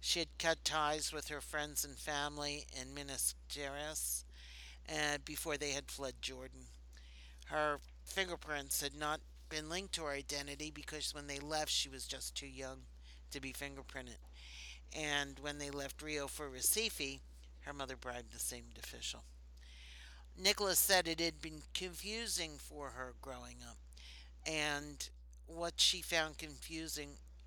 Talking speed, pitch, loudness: 145 wpm, 140 Hz, -39 LUFS